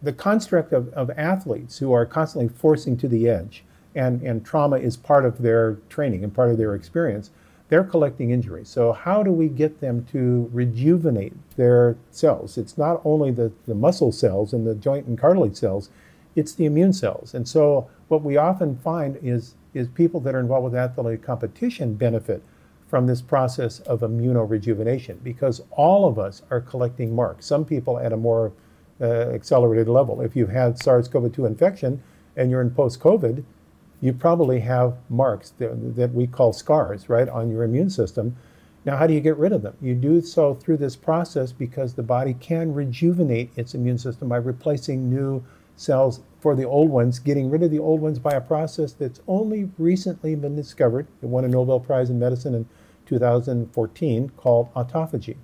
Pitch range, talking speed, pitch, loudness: 120-150 Hz, 185 wpm, 125 Hz, -22 LUFS